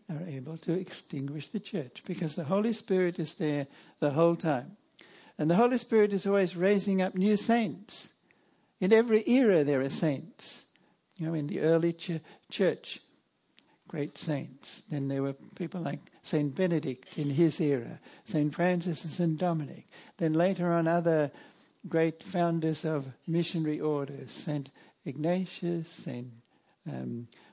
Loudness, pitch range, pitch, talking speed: -30 LUFS, 150-190 Hz, 170 Hz, 145 wpm